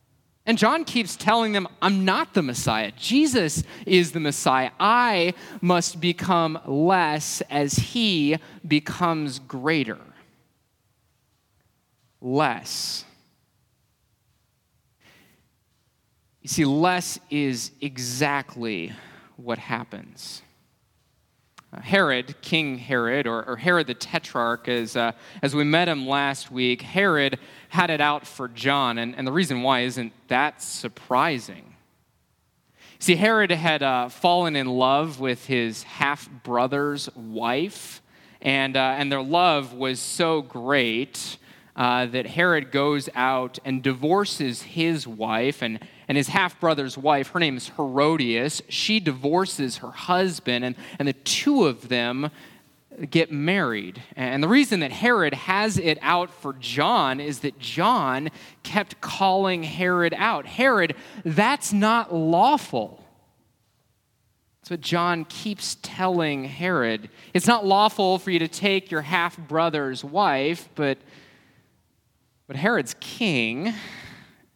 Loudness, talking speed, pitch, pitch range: -23 LUFS, 120 wpm, 145 Hz, 130-180 Hz